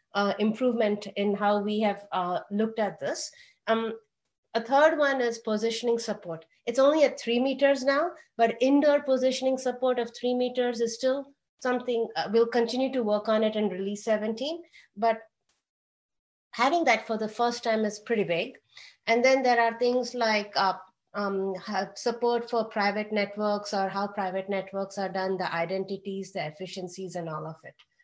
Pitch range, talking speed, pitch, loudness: 200-250 Hz, 170 wpm, 225 Hz, -27 LUFS